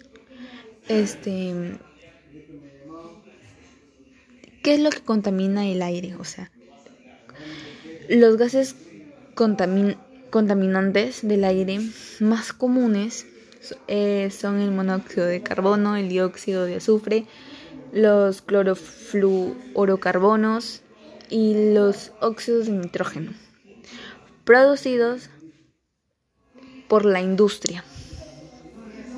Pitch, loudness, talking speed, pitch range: 210 Hz, -21 LUFS, 75 wpm, 190-230 Hz